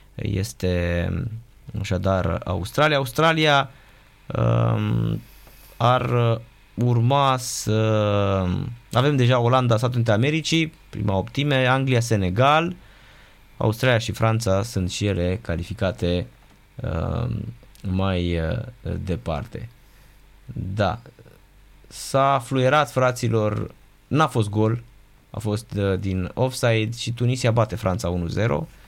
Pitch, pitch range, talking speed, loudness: 115 Hz, 100-130 Hz, 95 wpm, -22 LUFS